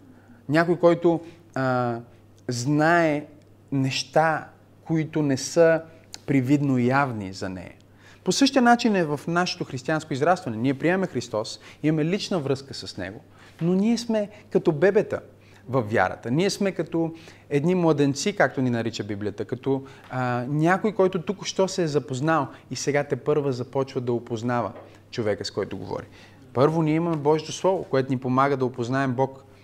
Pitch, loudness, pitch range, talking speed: 140 Hz, -24 LUFS, 120-165 Hz, 150 wpm